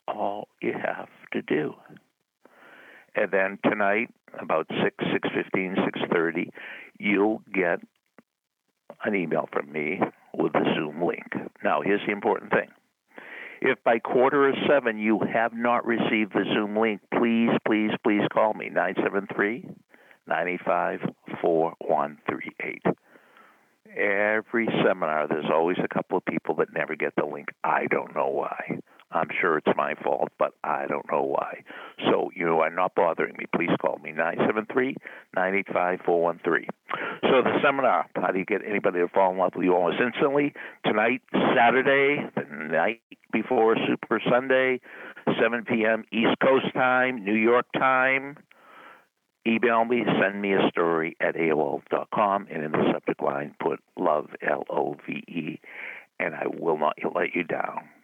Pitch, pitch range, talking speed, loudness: 110 Hz, 95-125 Hz, 145 wpm, -25 LUFS